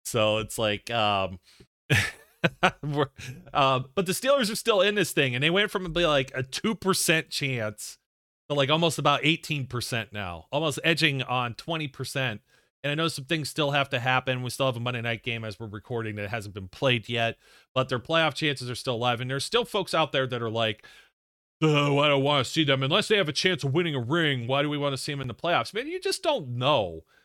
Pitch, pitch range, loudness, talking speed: 135 Hz, 120-160 Hz, -26 LUFS, 230 wpm